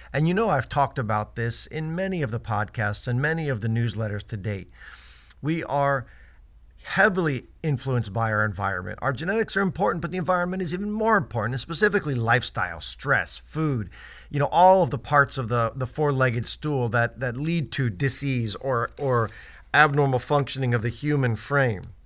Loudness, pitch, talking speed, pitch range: -24 LUFS, 130 Hz, 180 wpm, 115-155 Hz